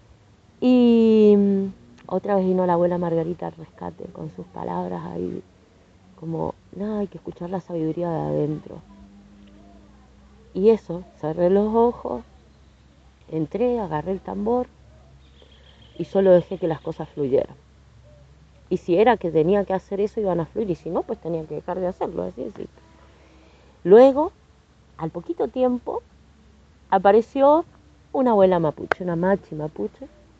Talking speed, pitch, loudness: 140 wpm, 170 Hz, -22 LUFS